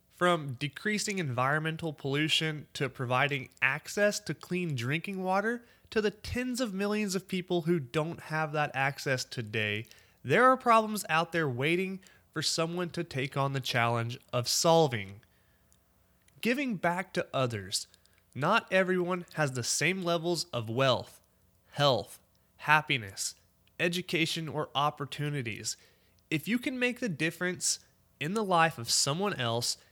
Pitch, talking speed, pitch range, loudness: 155 Hz, 135 wpm, 130-180 Hz, -30 LUFS